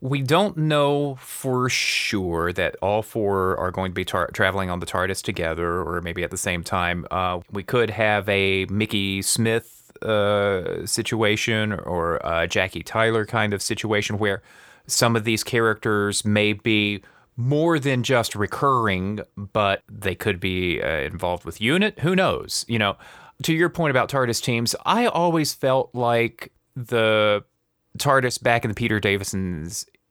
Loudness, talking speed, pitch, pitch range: -22 LUFS, 160 wpm, 105 Hz, 95-125 Hz